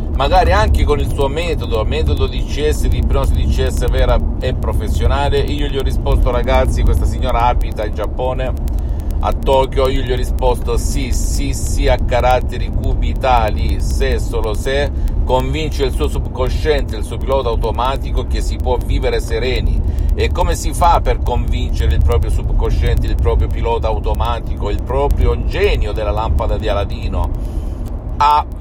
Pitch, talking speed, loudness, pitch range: 80 Hz, 155 wpm, -17 LUFS, 70-100 Hz